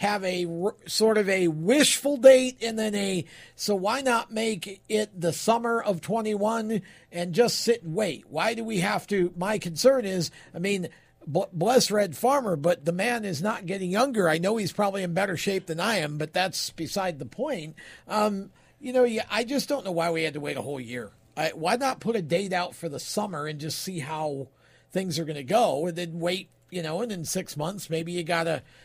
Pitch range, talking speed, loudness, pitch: 165-220 Hz, 220 wpm, -26 LUFS, 190 Hz